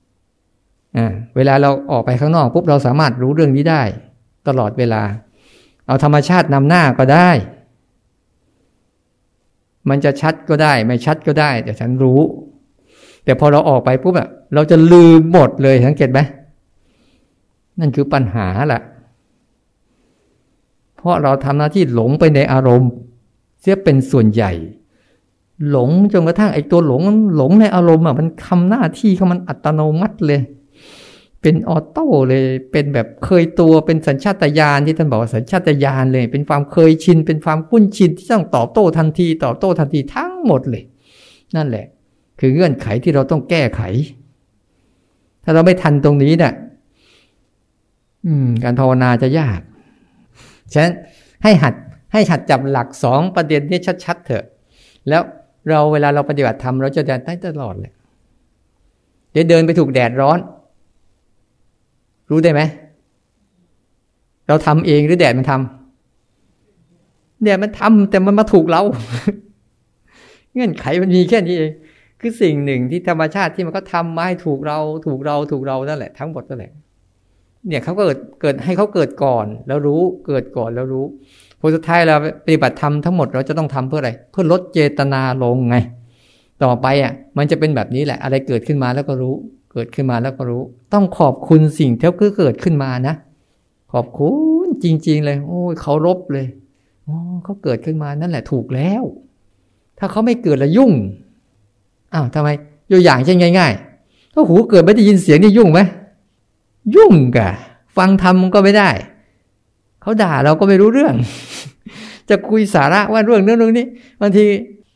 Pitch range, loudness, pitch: 125-175 Hz, -14 LUFS, 145 Hz